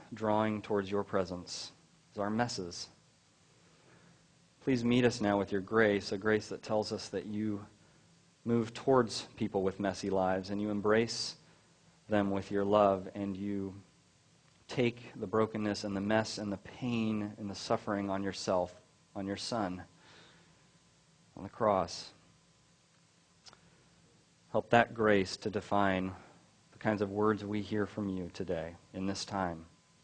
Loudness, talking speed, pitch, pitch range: -34 LUFS, 145 wpm, 105 Hz, 95-110 Hz